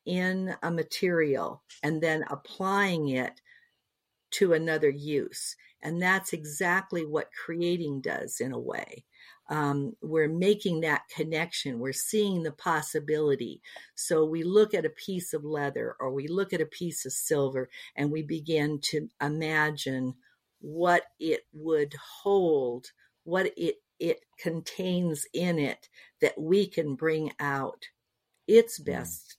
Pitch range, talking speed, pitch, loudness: 150-185 Hz, 135 wpm, 160 Hz, -29 LUFS